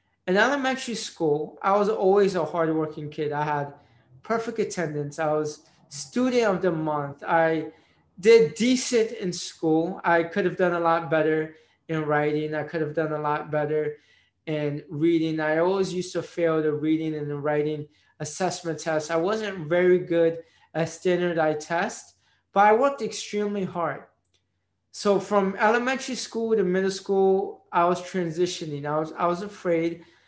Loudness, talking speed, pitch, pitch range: -25 LUFS, 160 wpm, 165 Hz, 155-195 Hz